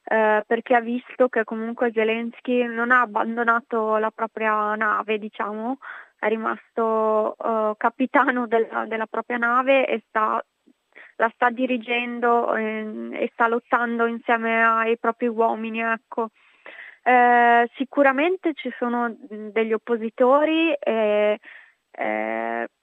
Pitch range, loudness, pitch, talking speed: 220-245 Hz, -22 LUFS, 230 Hz, 115 wpm